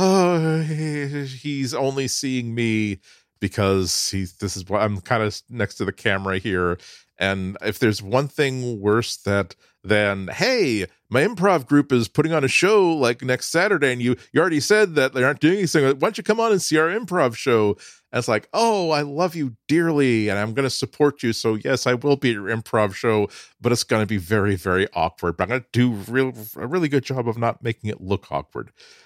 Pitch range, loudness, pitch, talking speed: 105-145 Hz, -21 LUFS, 120 Hz, 220 wpm